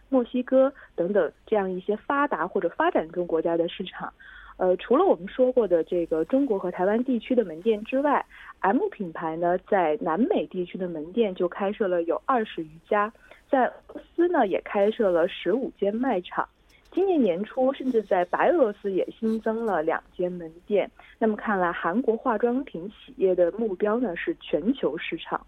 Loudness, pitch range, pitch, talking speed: -25 LUFS, 180-255 Hz, 215 Hz, 275 characters per minute